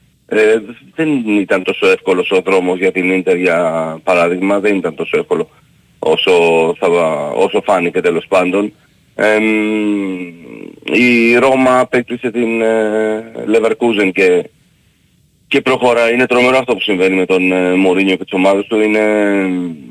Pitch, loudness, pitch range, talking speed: 110 Hz, -13 LUFS, 95-120 Hz, 140 wpm